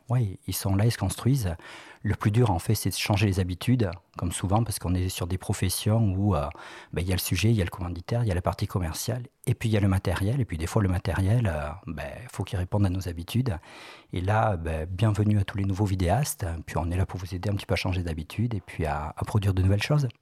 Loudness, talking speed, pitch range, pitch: -27 LUFS, 285 wpm, 90-110 Hz, 100 Hz